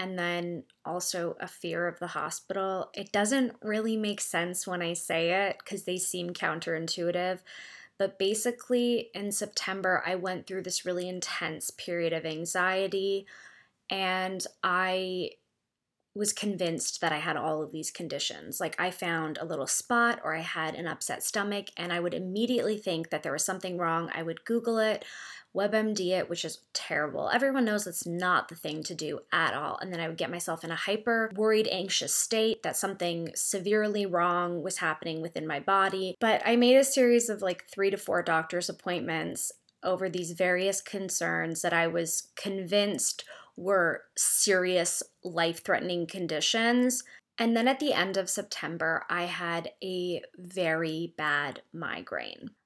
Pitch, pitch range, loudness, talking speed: 185 Hz, 170-205 Hz, -30 LUFS, 165 wpm